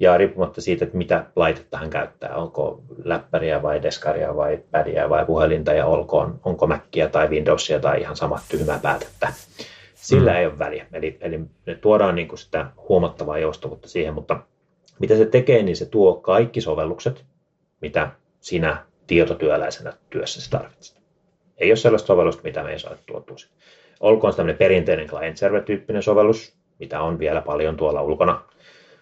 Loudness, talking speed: -21 LUFS, 160 wpm